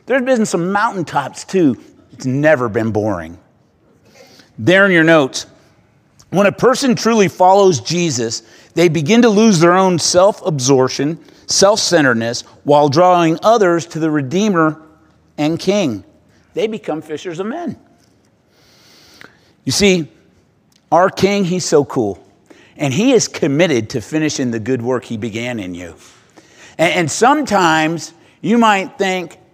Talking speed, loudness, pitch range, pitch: 135 wpm, -14 LUFS, 130-195 Hz, 165 Hz